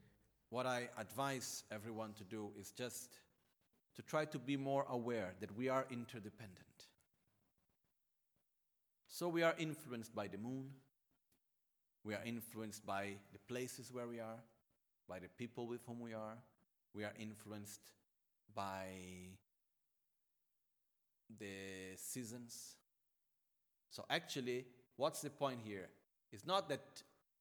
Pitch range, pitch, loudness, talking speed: 105-125 Hz, 115 Hz, -46 LUFS, 125 wpm